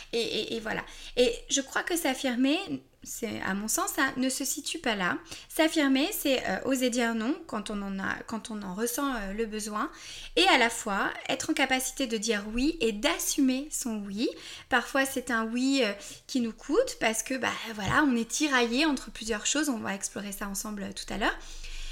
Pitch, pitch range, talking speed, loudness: 260 Hz, 225-290 Hz, 215 wpm, -29 LUFS